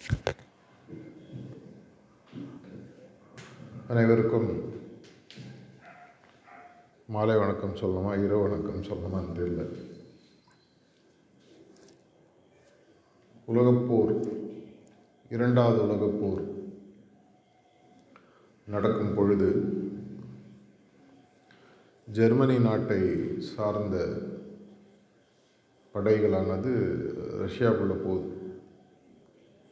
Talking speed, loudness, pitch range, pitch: 45 wpm, -28 LUFS, 95-115 Hz, 105 Hz